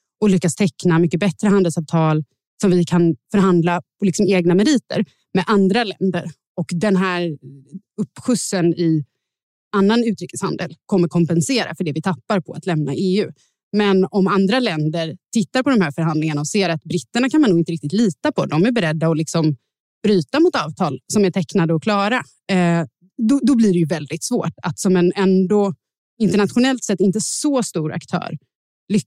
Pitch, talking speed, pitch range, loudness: 185 Hz, 175 wpm, 165-205 Hz, -18 LUFS